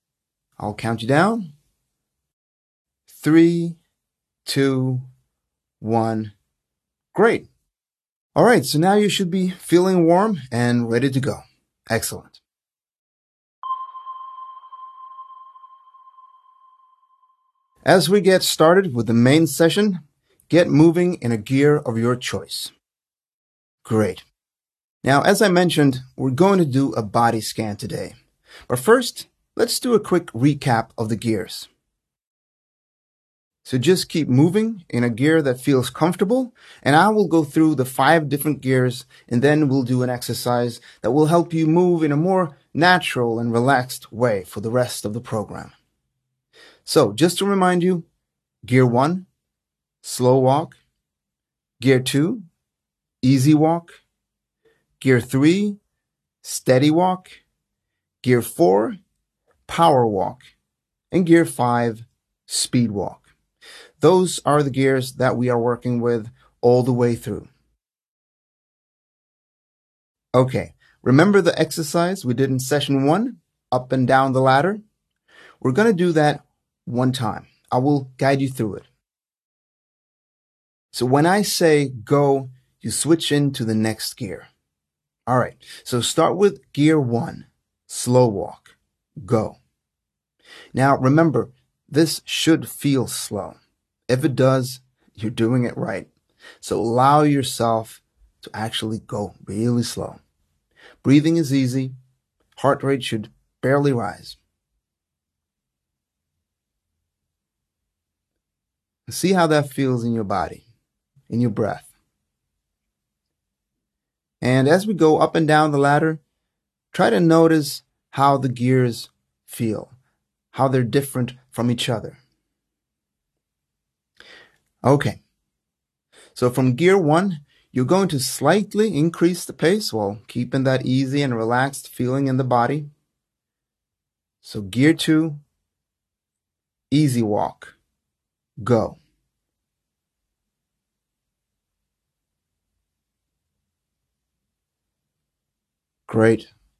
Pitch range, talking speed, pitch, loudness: 115-160 Hz, 115 wpm, 130 Hz, -19 LUFS